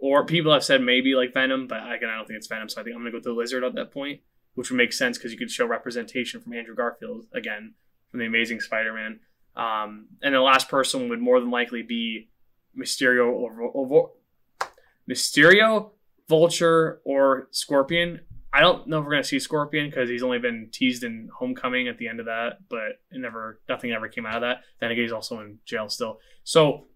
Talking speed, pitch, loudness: 220 wpm, 130 Hz, -23 LUFS